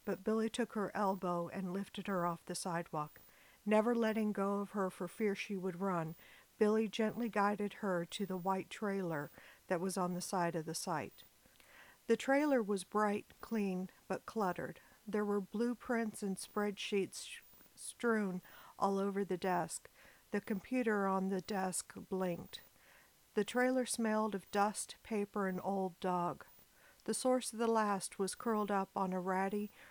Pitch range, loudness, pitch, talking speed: 185-215 Hz, -38 LUFS, 200 Hz, 160 wpm